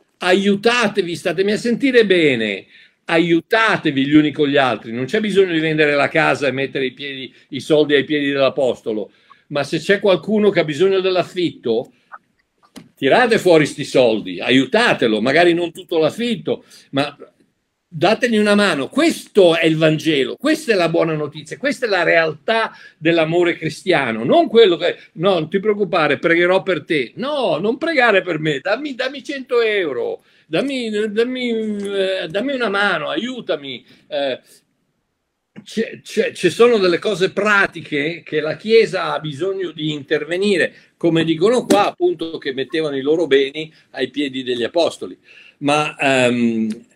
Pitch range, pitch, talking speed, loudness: 150-215 Hz, 175 Hz, 150 wpm, -17 LUFS